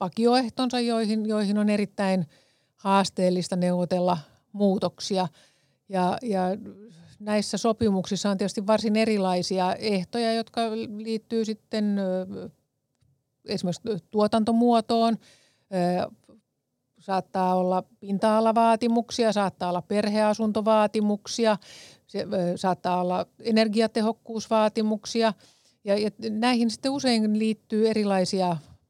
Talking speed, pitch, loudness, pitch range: 75 wpm, 210 Hz, -25 LUFS, 185-225 Hz